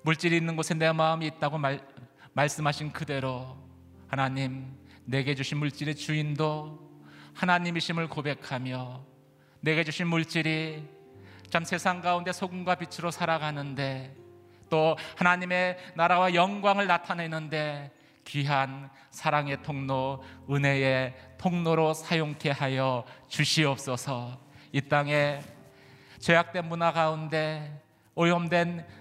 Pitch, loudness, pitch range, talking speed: 150 Hz, -28 LUFS, 135-165 Hz, 250 characters per minute